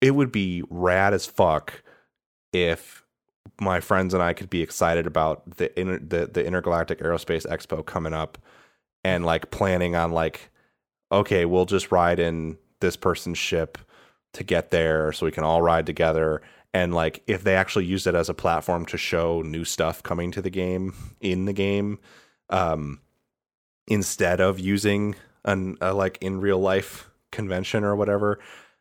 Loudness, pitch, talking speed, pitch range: -24 LUFS, 90 Hz, 165 wpm, 85-100 Hz